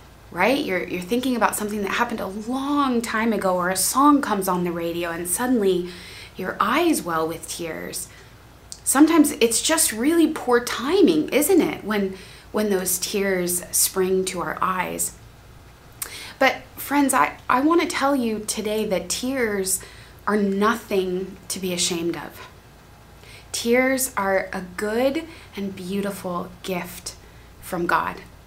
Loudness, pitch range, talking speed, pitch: -22 LUFS, 185-255 Hz, 145 wpm, 210 Hz